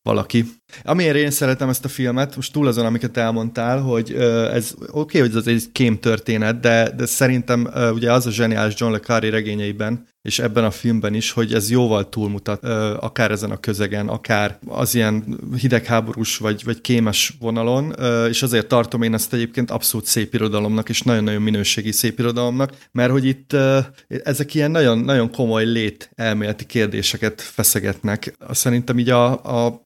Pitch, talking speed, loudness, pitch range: 115 Hz, 175 wpm, -19 LUFS, 110-125 Hz